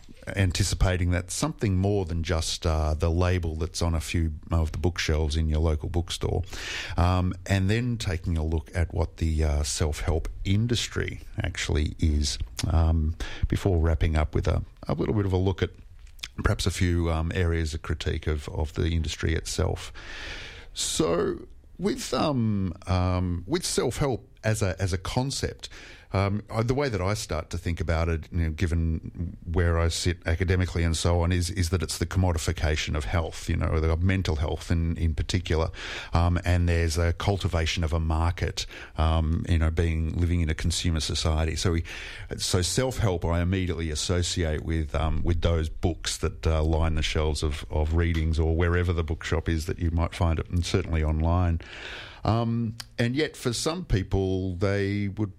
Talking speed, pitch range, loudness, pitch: 180 wpm, 80-95 Hz, -27 LUFS, 85 Hz